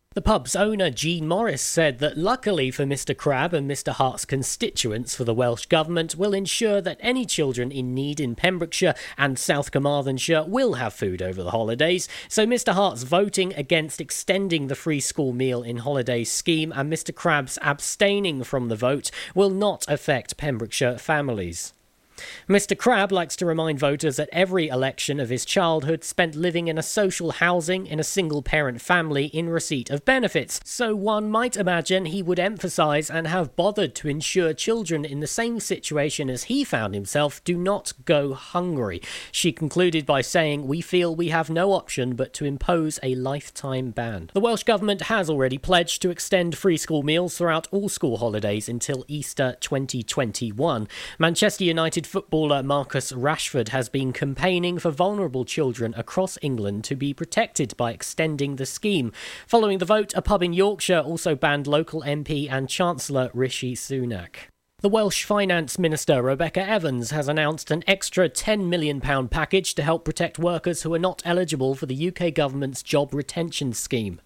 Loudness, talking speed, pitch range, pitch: -24 LUFS, 170 wpm, 135-180 Hz, 155 Hz